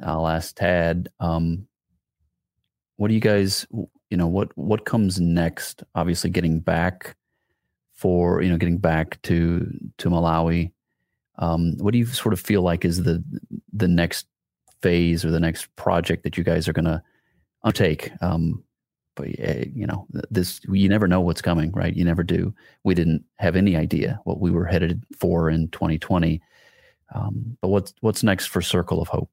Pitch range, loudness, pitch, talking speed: 80-95 Hz, -23 LUFS, 85 Hz, 170 wpm